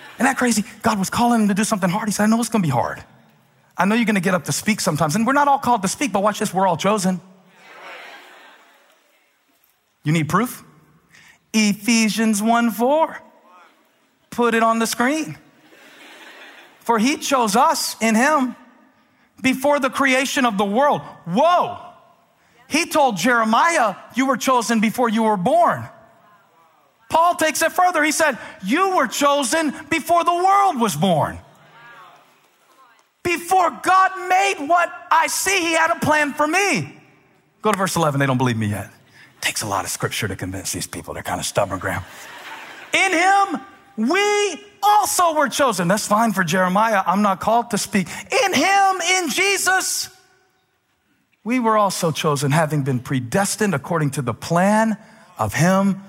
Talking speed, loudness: 170 wpm, -19 LUFS